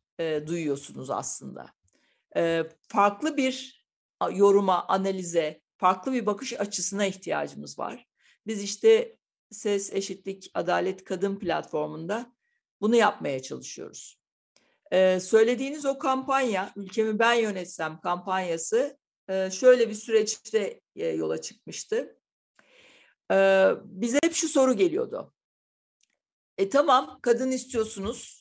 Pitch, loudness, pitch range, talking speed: 205 Hz, -26 LUFS, 185-260 Hz, 90 wpm